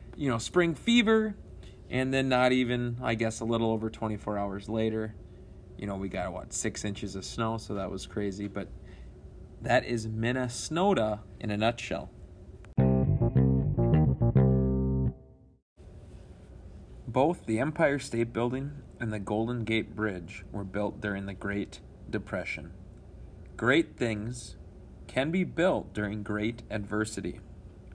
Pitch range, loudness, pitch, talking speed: 95-120 Hz, -30 LUFS, 105 Hz, 130 wpm